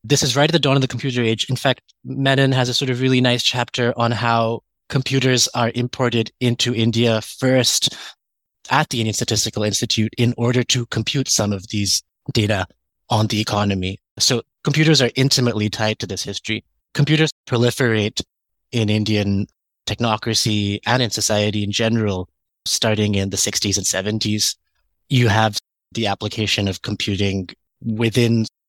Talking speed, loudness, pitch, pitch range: 155 wpm, -19 LUFS, 115 Hz, 105-125 Hz